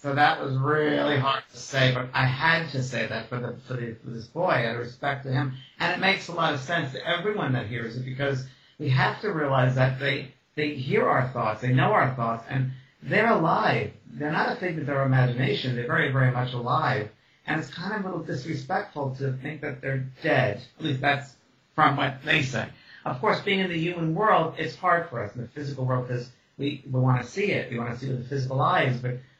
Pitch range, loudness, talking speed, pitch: 125-150 Hz, -26 LUFS, 240 wpm, 135 Hz